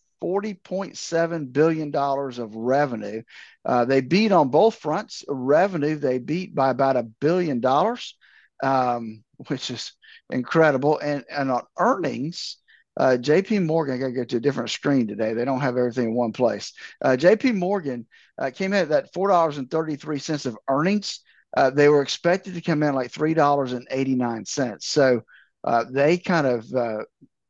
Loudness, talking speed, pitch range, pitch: -23 LUFS, 170 wpm, 125-170 Hz, 145 Hz